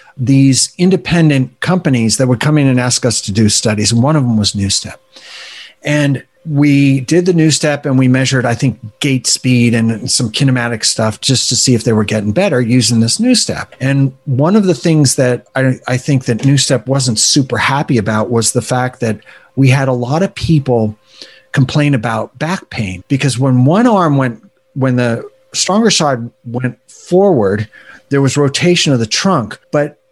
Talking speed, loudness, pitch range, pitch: 190 wpm, -12 LUFS, 120-145 Hz, 130 Hz